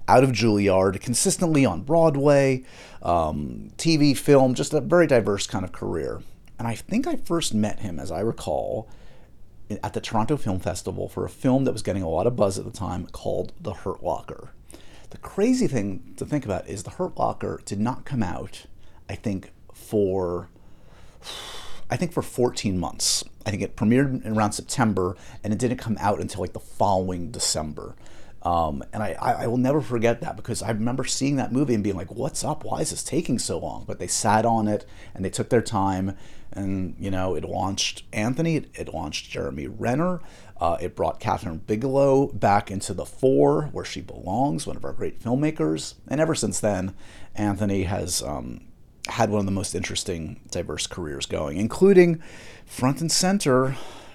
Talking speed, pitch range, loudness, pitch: 185 wpm, 95-130 Hz, -24 LUFS, 110 Hz